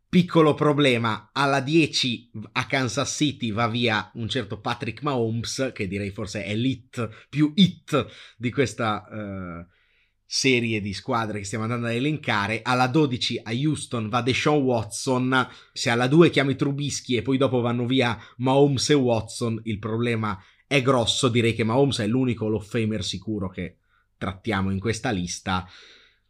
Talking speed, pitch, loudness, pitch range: 155 wpm, 120 Hz, -24 LUFS, 110-135 Hz